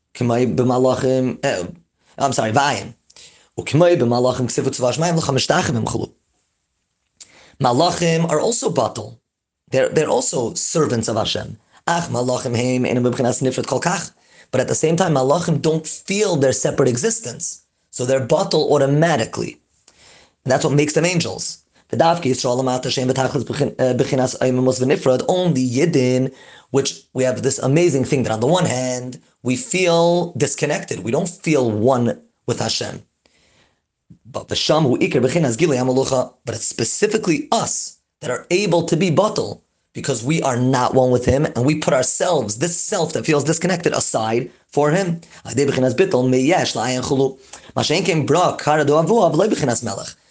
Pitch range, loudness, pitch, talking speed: 125-165 Hz, -18 LUFS, 135 Hz, 130 wpm